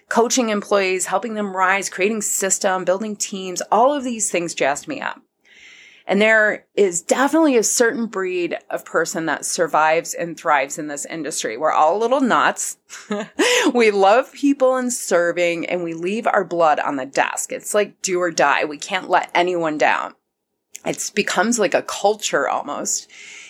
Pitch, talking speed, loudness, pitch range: 200 Hz, 170 wpm, -19 LUFS, 180-230 Hz